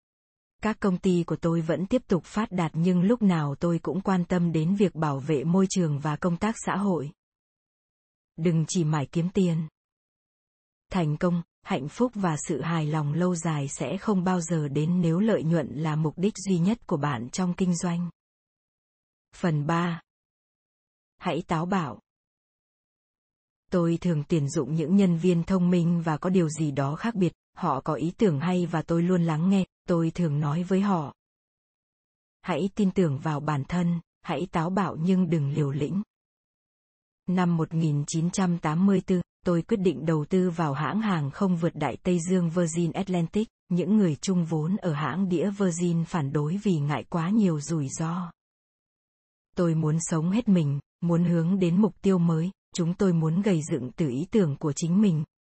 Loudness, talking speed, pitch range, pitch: -26 LUFS, 180 wpm, 160-185 Hz, 175 Hz